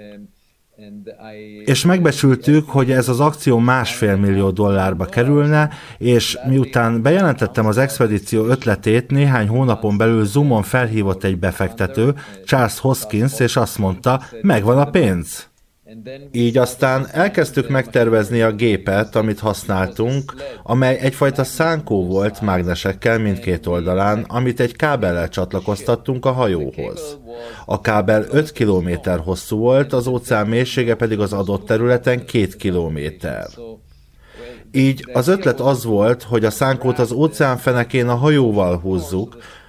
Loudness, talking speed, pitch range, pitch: -17 LUFS, 120 wpm, 105-130 Hz, 115 Hz